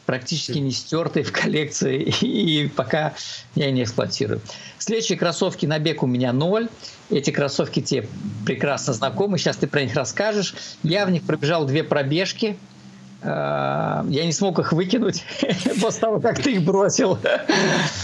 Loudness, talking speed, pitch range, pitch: -22 LUFS, 145 wpm, 145-200 Hz, 165 Hz